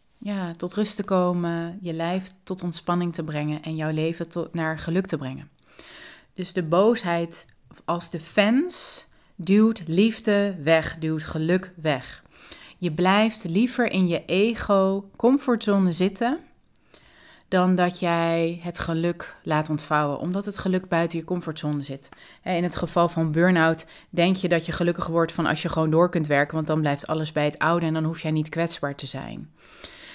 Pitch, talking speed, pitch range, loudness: 170 Hz, 170 wpm, 160-185 Hz, -24 LUFS